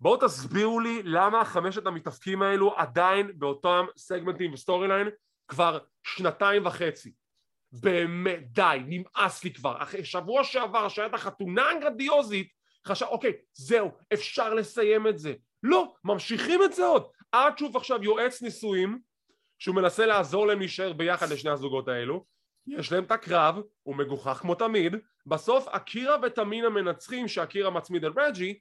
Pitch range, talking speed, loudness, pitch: 175-225 Hz, 145 wpm, -27 LUFS, 195 Hz